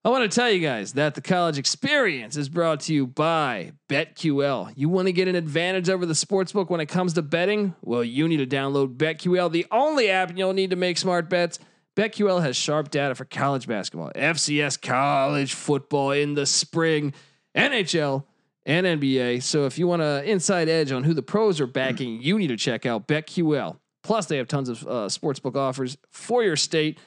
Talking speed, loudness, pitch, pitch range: 200 wpm, -23 LUFS, 155 Hz, 140-180 Hz